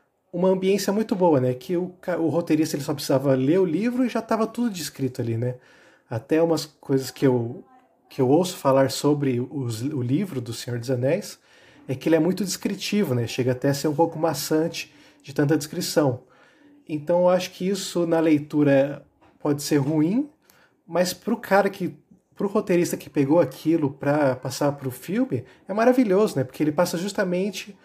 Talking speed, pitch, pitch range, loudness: 185 wpm, 160 Hz, 140-190 Hz, -23 LUFS